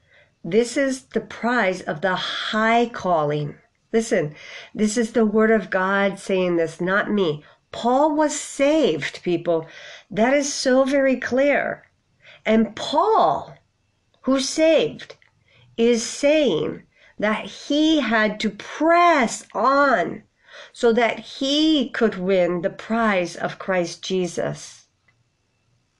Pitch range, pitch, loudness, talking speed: 180-265 Hz, 220 Hz, -21 LUFS, 115 wpm